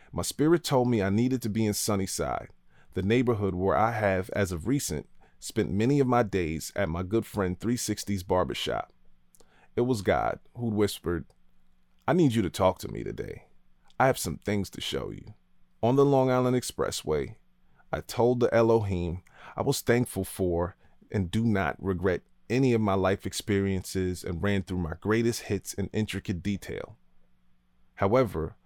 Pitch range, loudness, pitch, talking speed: 90-115 Hz, -28 LUFS, 100 Hz, 170 wpm